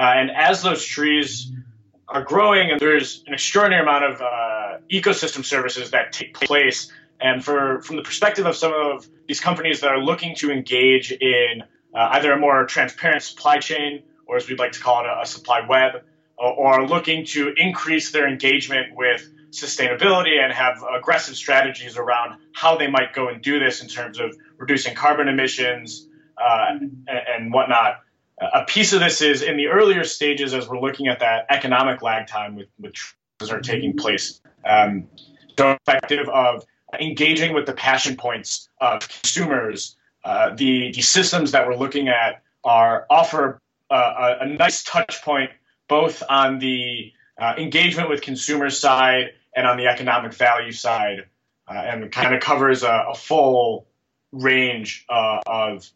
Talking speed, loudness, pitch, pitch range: 170 wpm, -19 LUFS, 135 Hz, 125-155 Hz